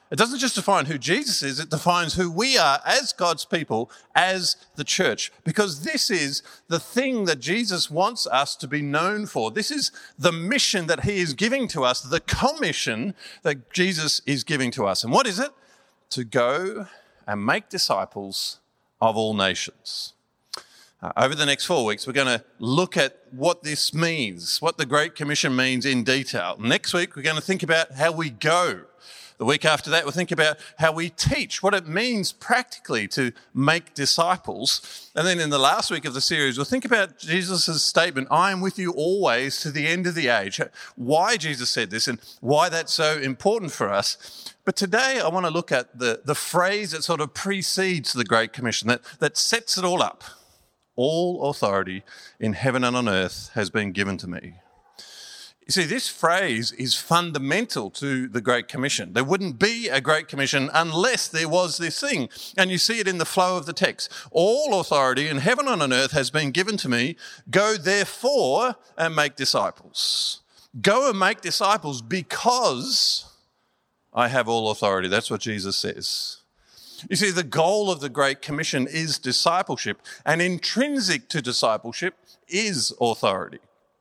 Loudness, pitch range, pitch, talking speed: -23 LUFS, 135-190 Hz, 160 Hz, 185 wpm